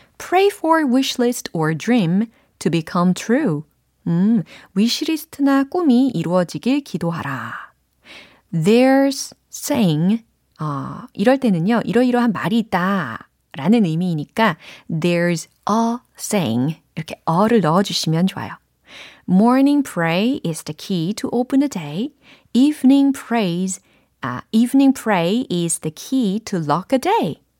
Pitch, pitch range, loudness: 210 Hz, 170-250 Hz, -18 LUFS